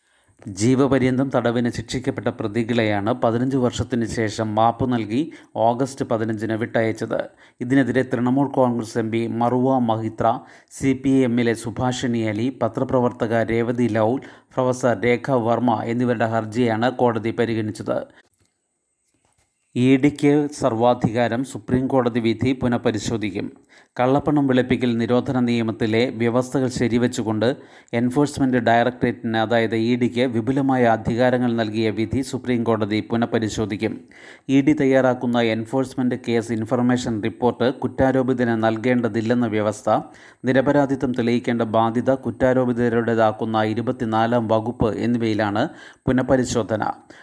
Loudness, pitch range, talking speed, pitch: -21 LUFS, 115-130 Hz, 95 wpm, 120 Hz